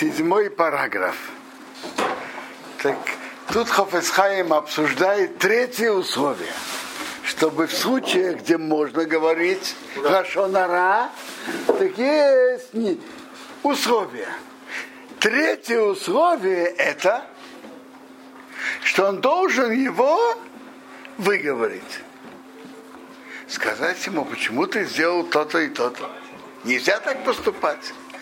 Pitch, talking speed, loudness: 230 Hz, 80 wpm, -21 LUFS